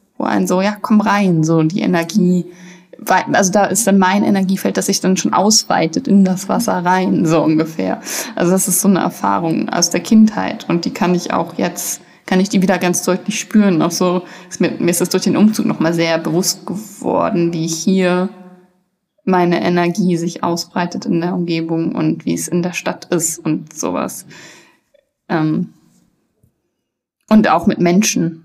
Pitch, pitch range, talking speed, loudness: 180 Hz, 170-195 Hz, 175 wpm, -15 LUFS